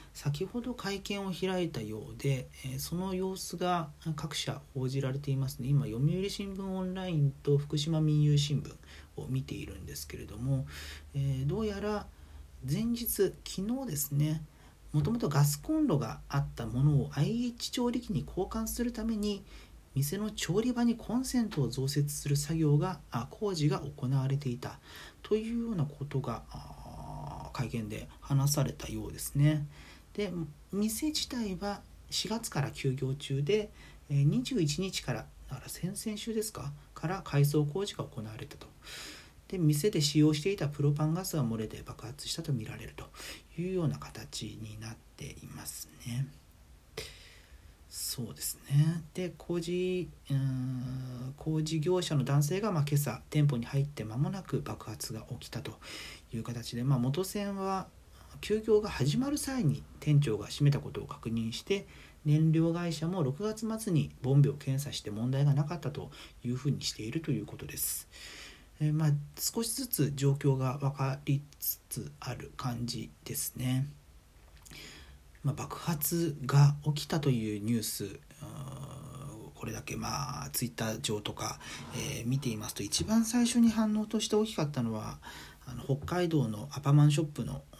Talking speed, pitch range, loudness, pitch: 295 characters per minute, 125-180 Hz, -33 LUFS, 145 Hz